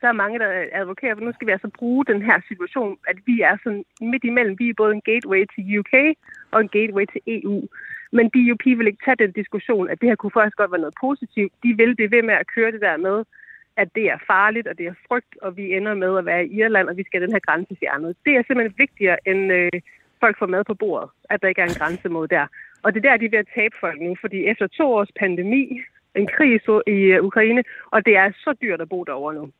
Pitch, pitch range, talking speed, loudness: 215 Hz, 190-240 Hz, 260 wpm, -19 LUFS